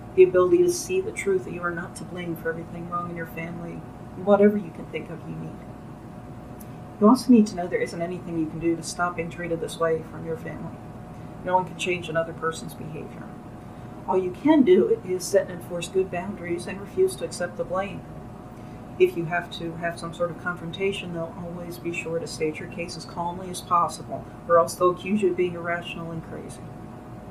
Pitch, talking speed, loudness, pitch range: 175 Hz, 220 wpm, -25 LUFS, 165-185 Hz